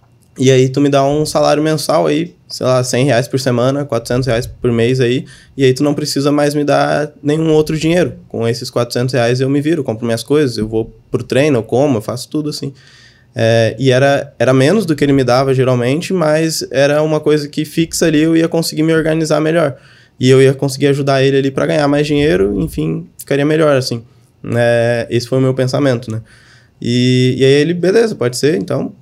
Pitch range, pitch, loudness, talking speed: 120-150 Hz, 135 Hz, -14 LUFS, 220 wpm